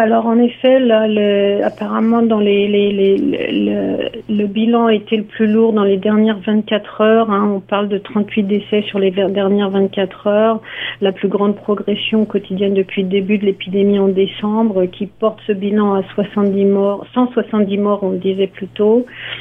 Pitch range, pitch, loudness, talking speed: 195-220 Hz, 205 Hz, -15 LUFS, 190 wpm